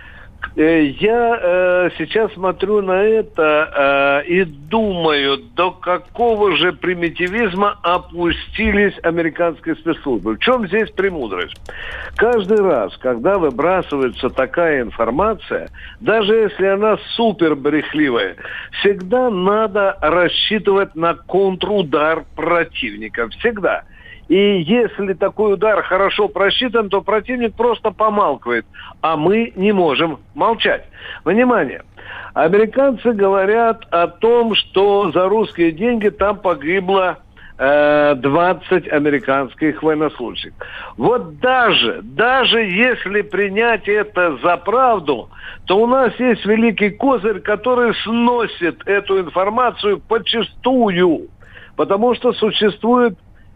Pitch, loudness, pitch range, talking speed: 195 Hz, -16 LUFS, 170-225 Hz, 100 wpm